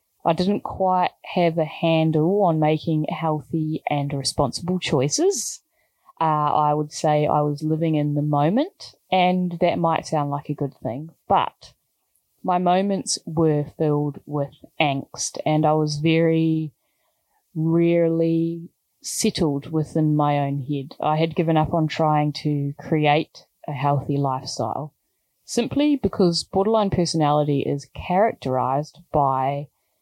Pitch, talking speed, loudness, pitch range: 155 Hz, 130 wpm, -22 LUFS, 145-170 Hz